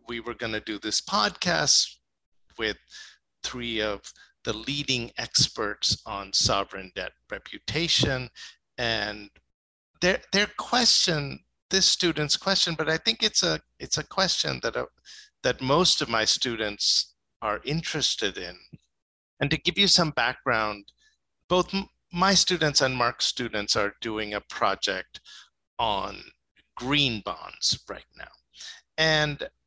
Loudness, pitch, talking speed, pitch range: -25 LUFS, 130 Hz, 130 wpm, 105-170 Hz